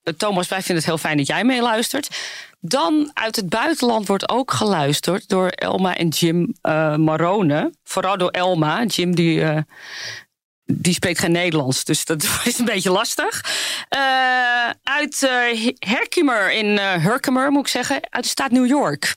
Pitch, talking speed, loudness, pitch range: 195 Hz, 165 wpm, -19 LUFS, 170-245 Hz